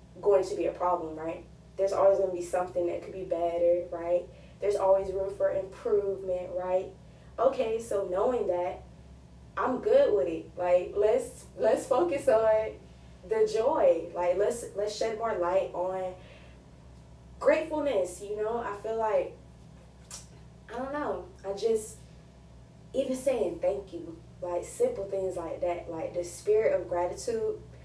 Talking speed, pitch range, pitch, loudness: 150 wpm, 175-220 Hz, 190 Hz, -29 LUFS